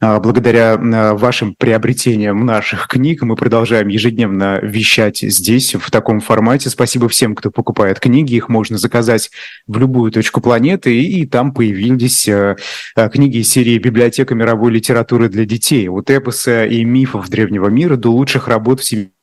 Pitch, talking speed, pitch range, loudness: 115 Hz, 145 wpm, 110-125 Hz, -12 LUFS